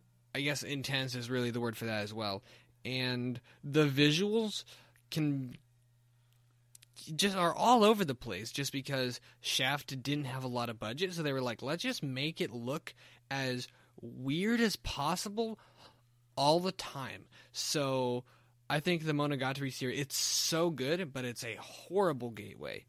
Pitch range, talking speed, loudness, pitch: 120-150 Hz, 155 wpm, -34 LUFS, 130 Hz